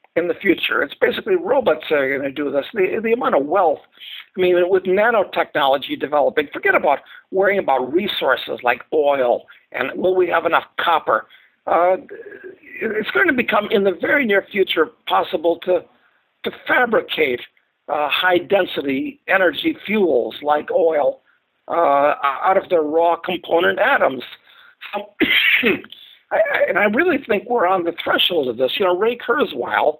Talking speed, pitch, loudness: 155 wpm, 195 Hz, -18 LUFS